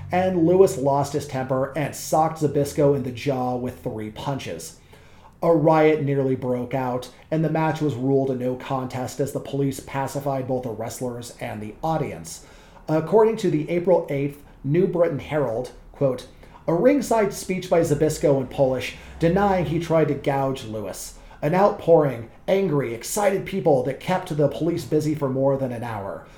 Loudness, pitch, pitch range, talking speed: -23 LUFS, 145 Hz, 130-165 Hz, 170 wpm